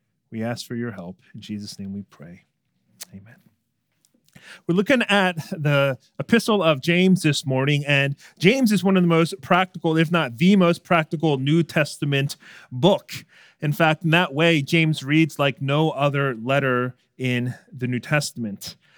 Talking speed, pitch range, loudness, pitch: 160 wpm, 125-170 Hz, -21 LUFS, 150 Hz